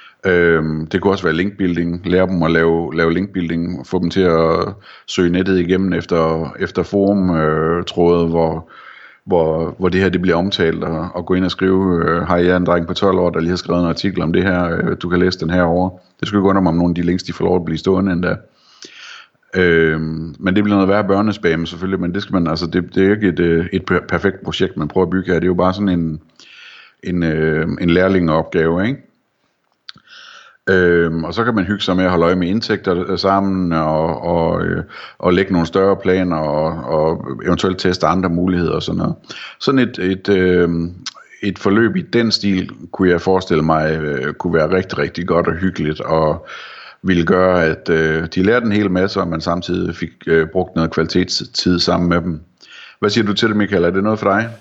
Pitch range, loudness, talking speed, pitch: 85-95 Hz, -16 LUFS, 210 wpm, 90 Hz